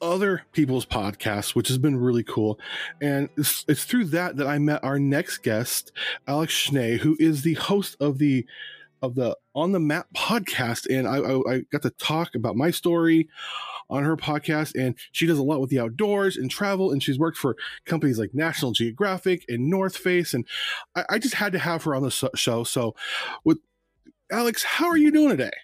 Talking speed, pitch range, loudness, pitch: 200 wpm, 130-180 Hz, -24 LUFS, 150 Hz